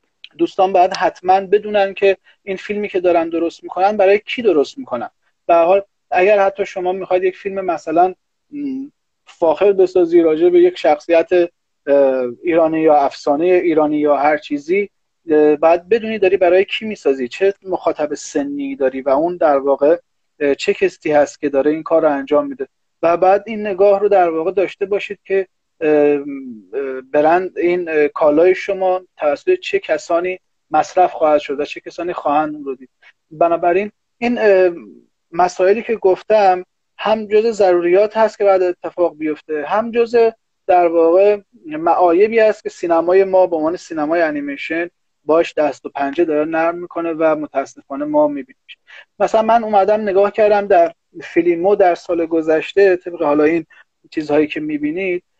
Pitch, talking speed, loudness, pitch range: 180 Hz, 150 wpm, -16 LUFS, 160-205 Hz